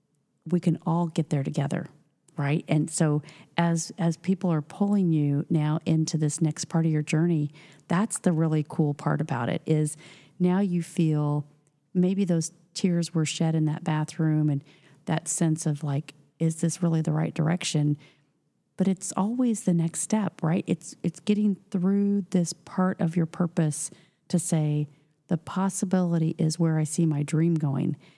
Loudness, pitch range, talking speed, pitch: -26 LUFS, 155-180 Hz, 170 wpm, 165 Hz